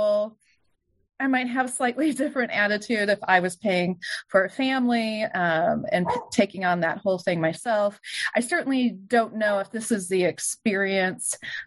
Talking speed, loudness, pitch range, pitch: 165 wpm, -24 LUFS, 190-250 Hz, 215 Hz